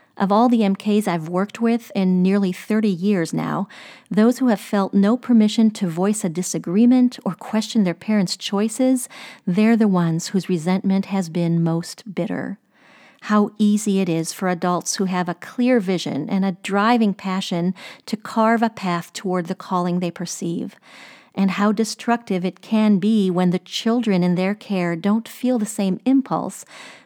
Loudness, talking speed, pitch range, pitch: -20 LUFS, 170 wpm, 185-225 Hz, 200 Hz